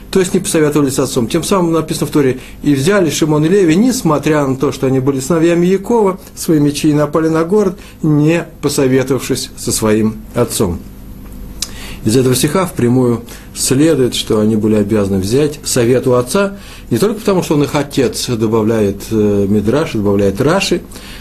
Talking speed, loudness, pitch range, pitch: 165 wpm, -13 LUFS, 120-170 Hz, 145 Hz